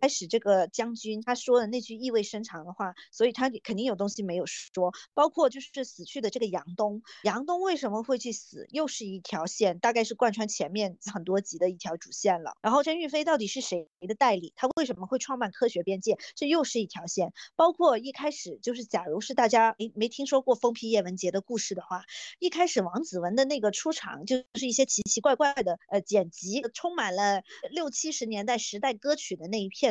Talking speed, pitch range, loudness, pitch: 325 characters per minute, 200-265 Hz, -29 LUFS, 230 Hz